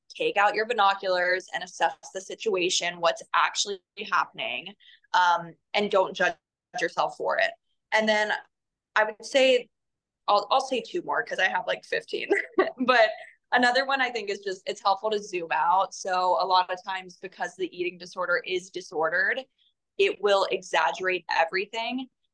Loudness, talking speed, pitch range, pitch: -26 LUFS, 160 wpm, 180-260 Hz, 200 Hz